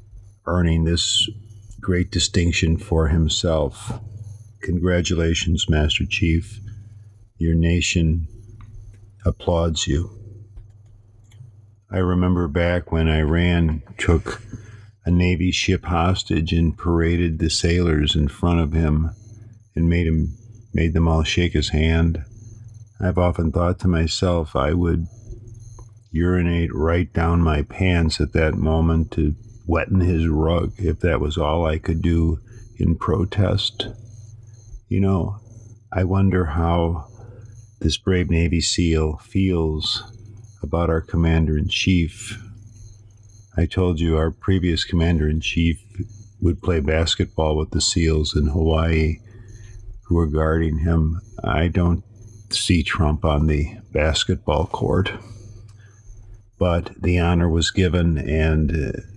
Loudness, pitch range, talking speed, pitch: -21 LUFS, 80-105 Hz, 120 wpm, 90 Hz